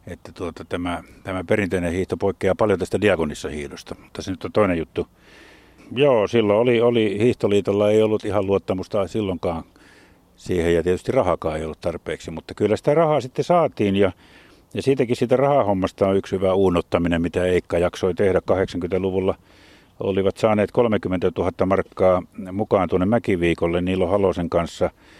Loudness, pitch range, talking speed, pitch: -21 LUFS, 85-105 Hz, 155 wpm, 95 Hz